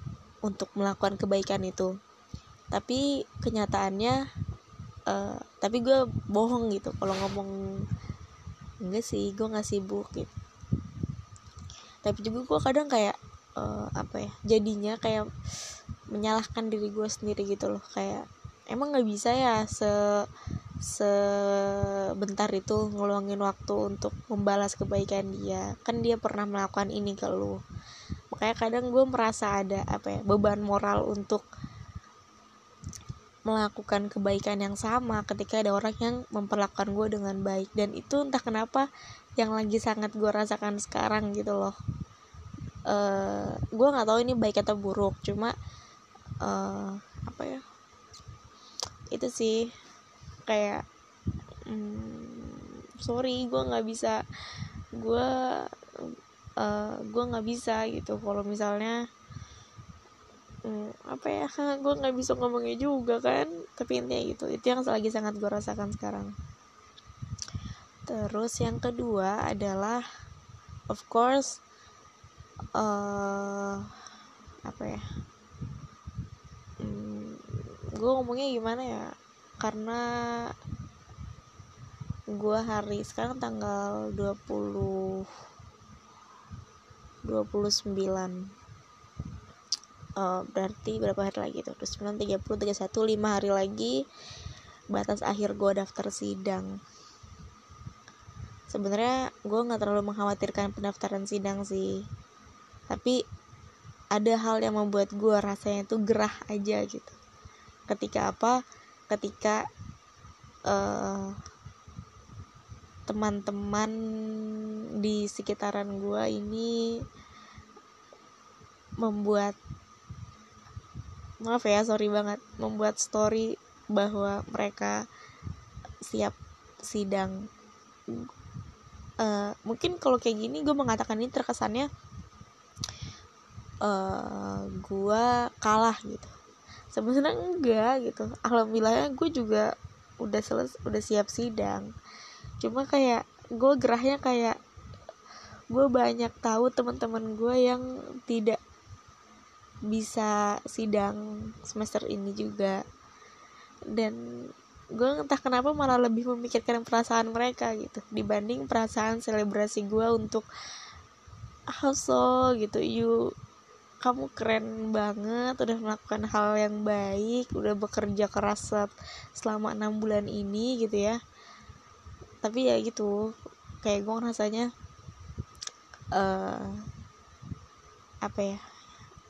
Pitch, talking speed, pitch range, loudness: 210 Hz, 100 wpm, 195-230 Hz, -30 LUFS